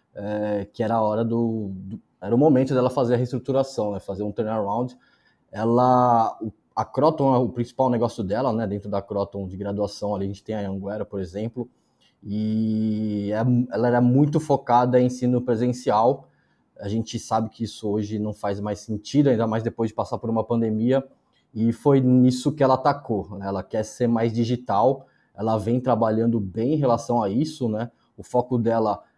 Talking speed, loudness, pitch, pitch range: 190 wpm, -23 LUFS, 115 Hz, 105-125 Hz